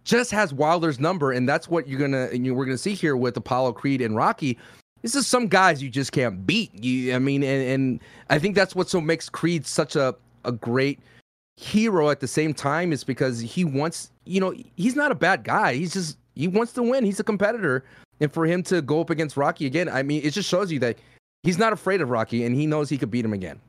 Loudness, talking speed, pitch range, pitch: -23 LUFS, 250 wpm, 130-180 Hz, 150 Hz